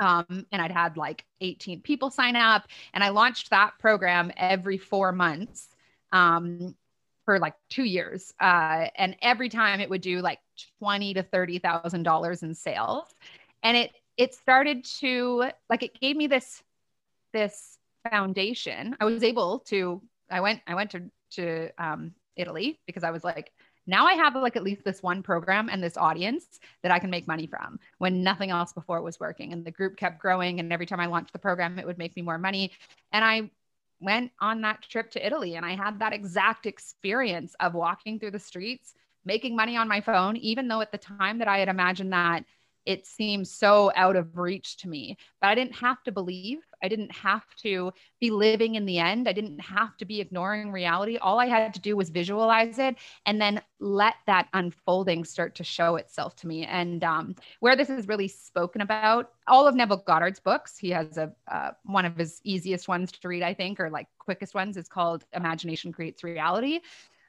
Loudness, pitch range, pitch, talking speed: -26 LUFS, 175-220 Hz, 195 Hz, 200 wpm